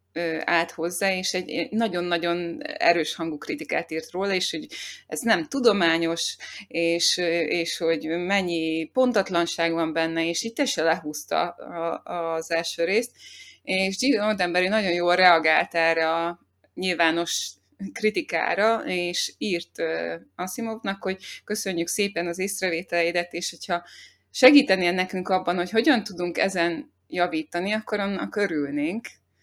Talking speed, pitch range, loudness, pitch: 125 wpm, 165-195 Hz, -24 LUFS, 175 Hz